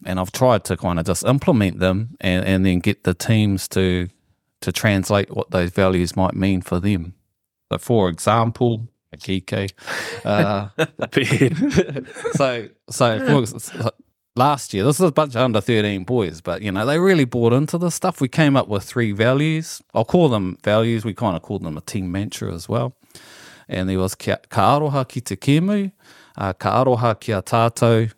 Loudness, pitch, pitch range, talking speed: -20 LUFS, 105 Hz, 95-125 Hz, 165 wpm